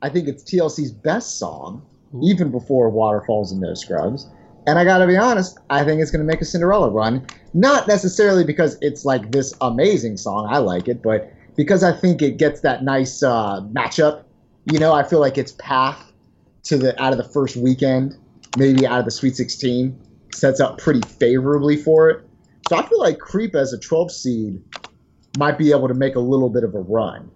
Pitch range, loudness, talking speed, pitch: 125-160 Hz, -18 LUFS, 200 wpm, 135 Hz